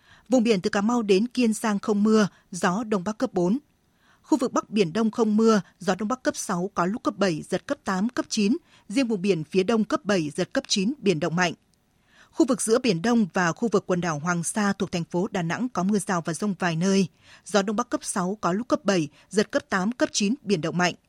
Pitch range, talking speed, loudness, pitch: 180-230 Hz, 255 wpm, -25 LUFS, 205 Hz